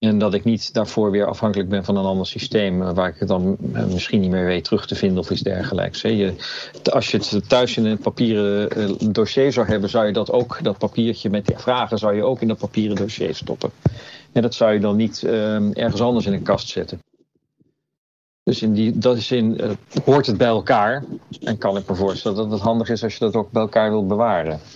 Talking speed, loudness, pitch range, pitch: 230 wpm, -20 LUFS, 100-115 Hz, 110 Hz